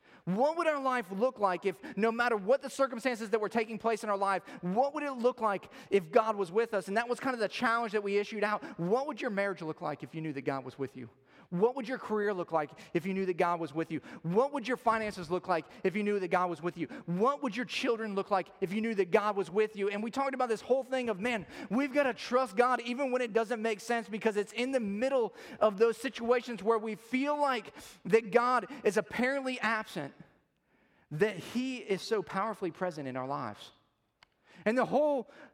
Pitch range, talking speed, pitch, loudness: 195-250 Hz, 245 wpm, 220 Hz, -32 LUFS